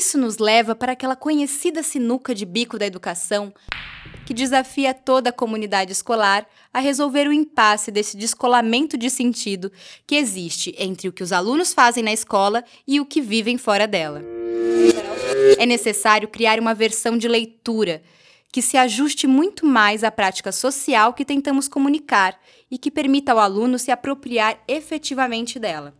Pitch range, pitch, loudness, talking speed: 210-275 Hz, 235 Hz, -19 LUFS, 155 wpm